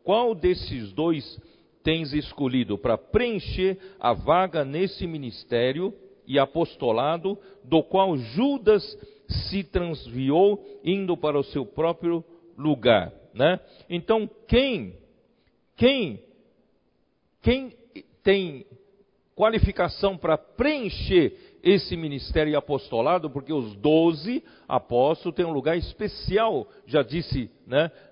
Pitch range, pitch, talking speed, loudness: 150-205 Hz, 175 Hz, 100 wpm, -25 LUFS